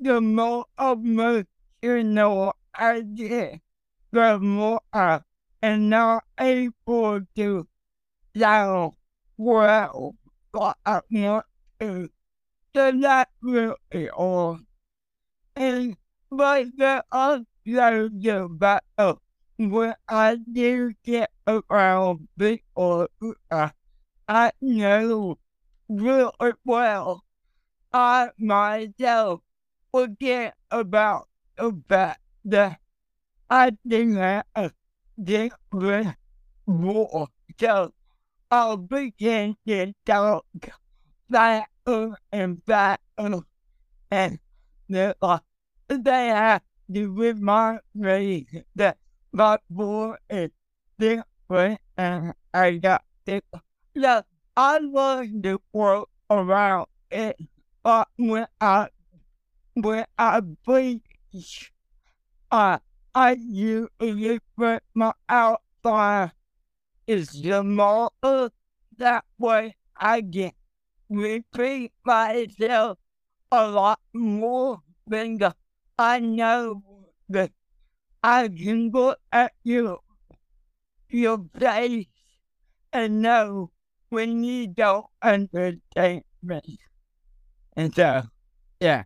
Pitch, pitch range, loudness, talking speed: 215 Hz, 190-235 Hz, -23 LUFS, 90 wpm